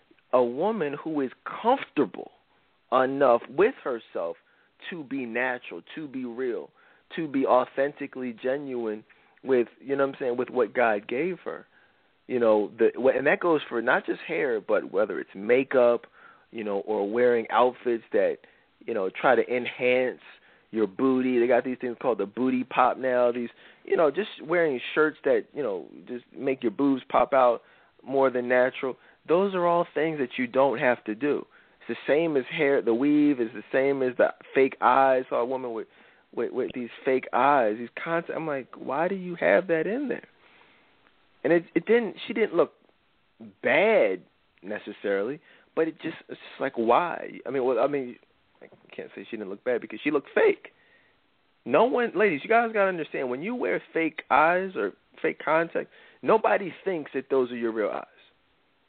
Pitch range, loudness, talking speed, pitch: 125-175 Hz, -26 LUFS, 185 wpm, 135 Hz